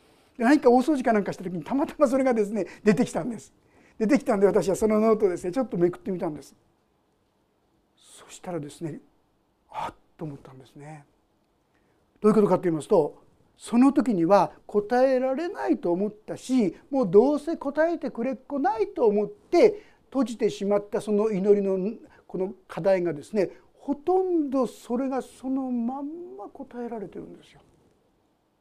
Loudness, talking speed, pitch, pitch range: -25 LUFS, 365 characters per minute, 220 Hz, 190-270 Hz